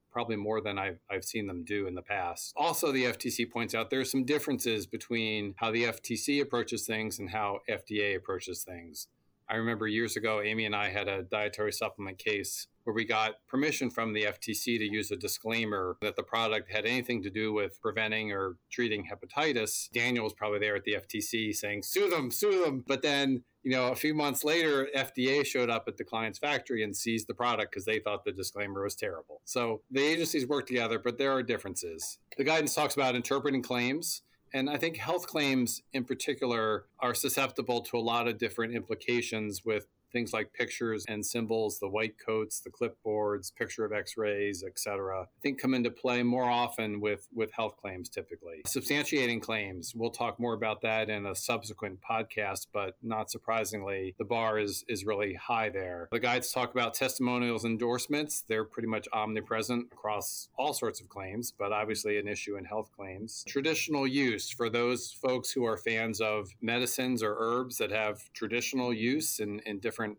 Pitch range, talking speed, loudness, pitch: 105-125 Hz, 190 wpm, -32 LUFS, 115 Hz